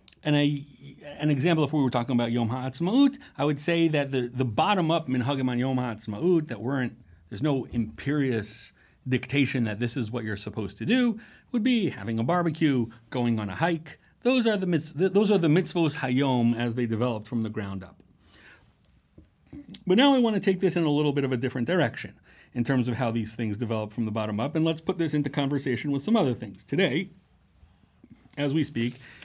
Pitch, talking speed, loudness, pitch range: 135 Hz, 205 wpm, -26 LUFS, 120-165 Hz